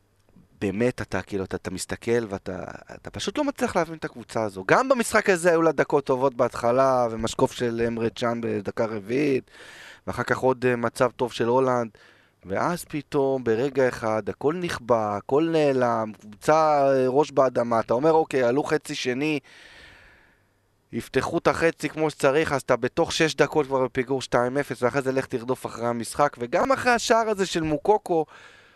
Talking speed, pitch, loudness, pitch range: 165 wpm, 130 Hz, -24 LUFS, 115-155 Hz